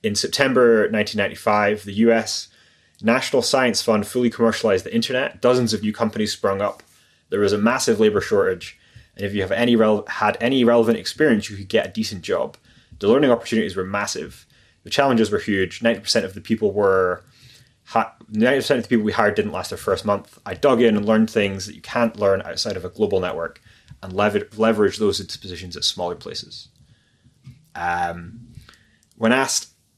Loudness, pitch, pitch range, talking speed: -20 LUFS, 110 Hz, 100-120 Hz, 180 wpm